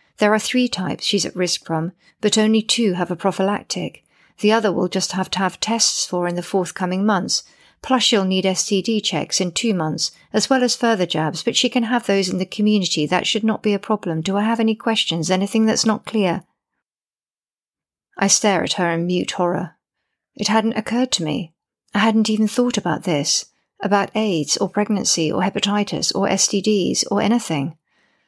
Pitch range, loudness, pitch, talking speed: 180-220 Hz, -19 LUFS, 200 Hz, 195 wpm